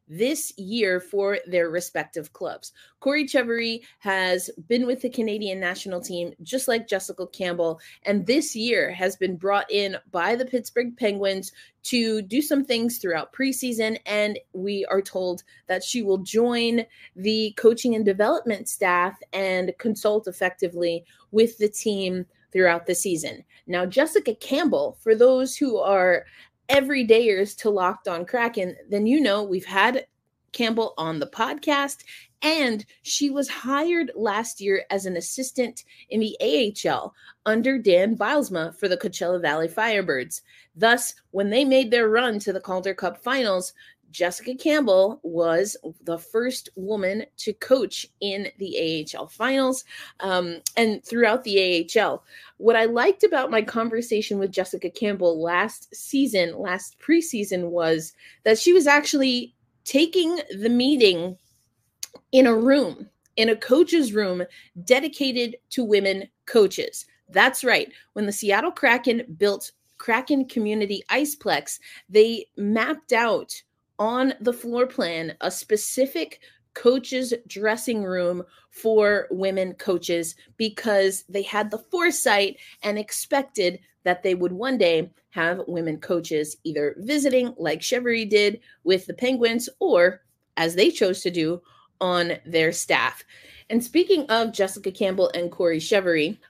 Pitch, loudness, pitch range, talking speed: 210 Hz, -23 LUFS, 185-250 Hz, 140 wpm